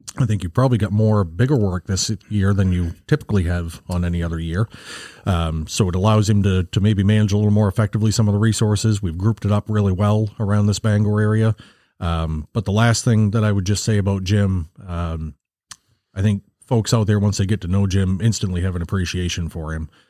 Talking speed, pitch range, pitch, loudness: 225 wpm, 90-110 Hz, 105 Hz, -19 LUFS